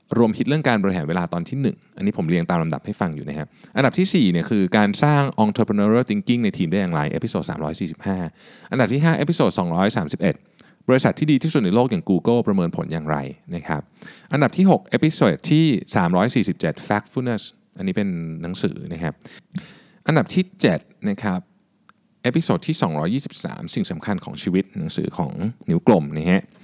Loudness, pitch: -21 LUFS, 125 Hz